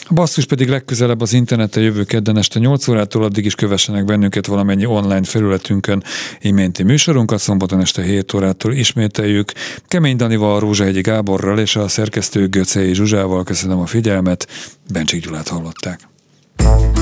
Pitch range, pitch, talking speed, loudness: 95-110 Hz, 105 Hz, 140 wpm, -15 LUFS